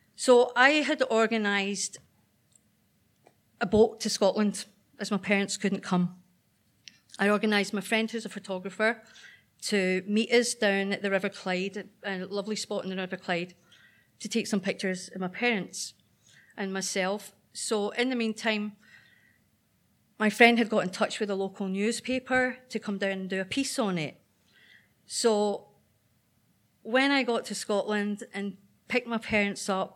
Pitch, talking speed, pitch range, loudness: 205 Hz, 155 wpm, 195-225 Hz, -28 LUFS